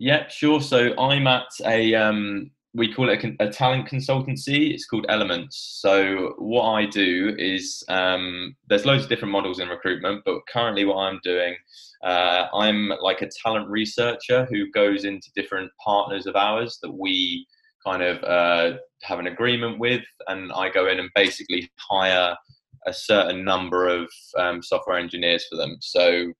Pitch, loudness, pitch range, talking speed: 100 Hz, -22 LUFS, 90-125 Hz, 170 wpm